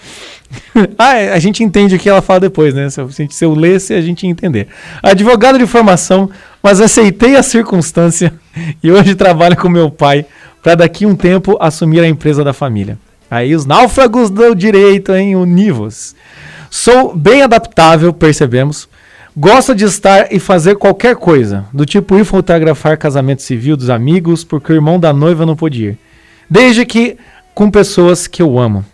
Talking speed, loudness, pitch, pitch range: 175 wpm, -8 LUFS, 175 Hz, 155-200 Hz